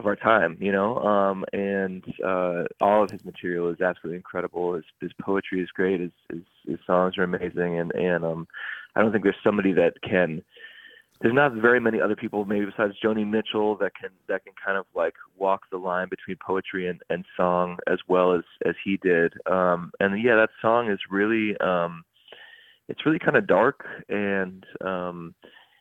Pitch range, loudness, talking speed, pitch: 90-110 Hz, -25 LUFS, 190 wpm, 95 Hz